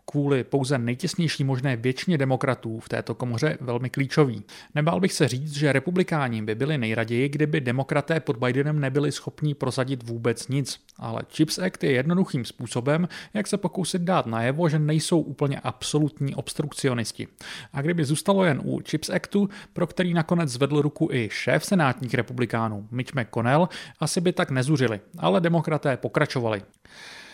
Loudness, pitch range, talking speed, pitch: -25 LUFS, 125-160 Hz, 155 wpm, 145 Hz